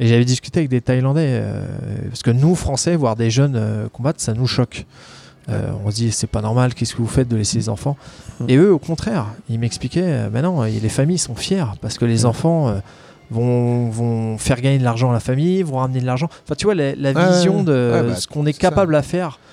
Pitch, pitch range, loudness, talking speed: 125 Hz, 115-150 Hz, -18 LUFS, 245 wpm